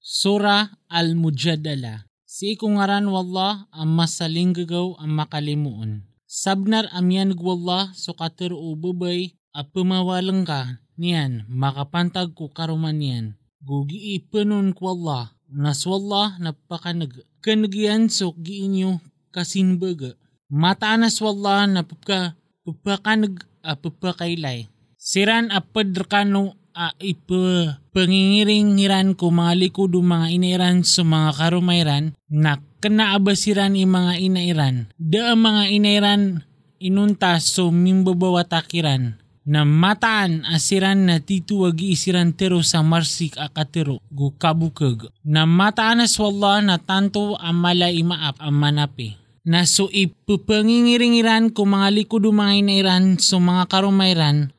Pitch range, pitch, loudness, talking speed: 155-195 Hz, 180 Hz, -19 LUFS, 110 wpm